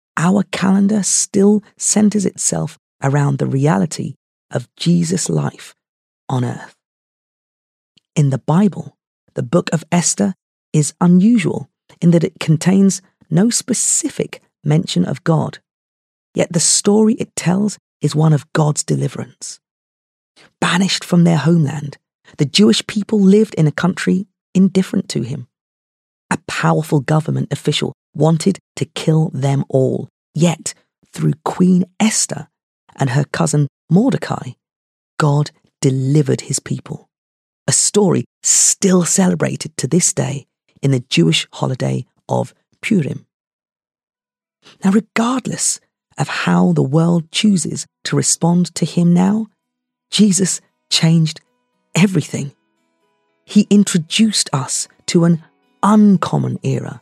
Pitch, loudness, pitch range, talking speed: 170 Hz, -16 LUFS, 145-195 Hz, 115 wpm